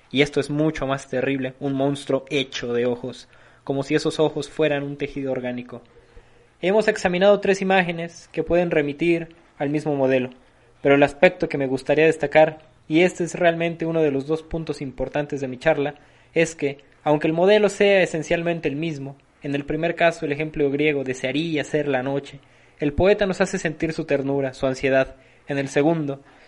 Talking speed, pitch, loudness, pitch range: 185 wpm, 145 Hz, -22 LUFS, 135-165 Hz